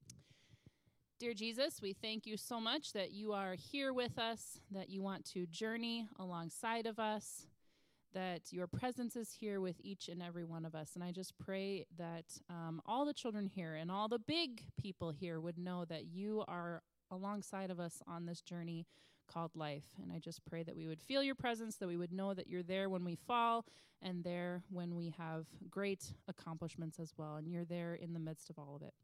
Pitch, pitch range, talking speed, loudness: 180 Hz, 165-215 Hz, 210 wpm, -44 LUFS